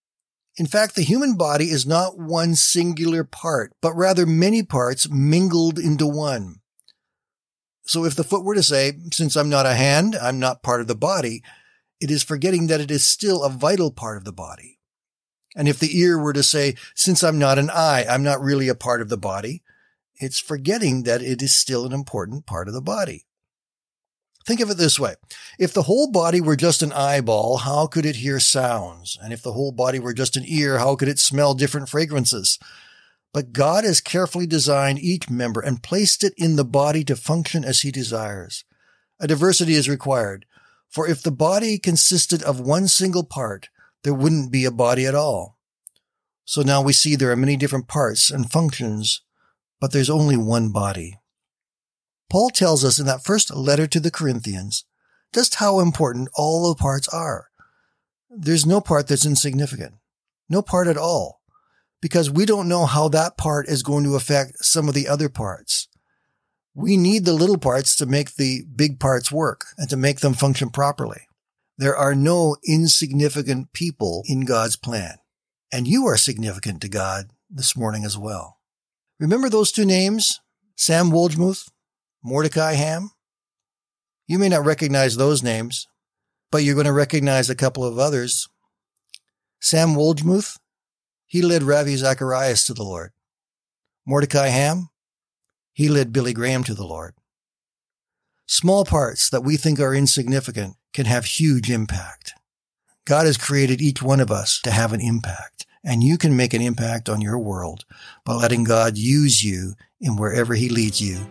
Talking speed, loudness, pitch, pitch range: 175 wpm, -19 LUFS, 140 Hz, 125-165 Hz